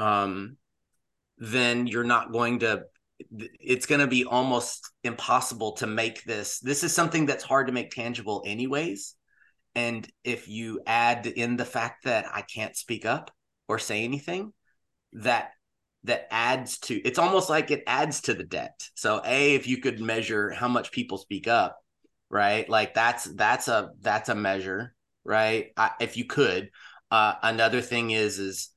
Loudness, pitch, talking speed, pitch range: -26 LUFS, 120 Hz, 165 wpm, 110-130 Hz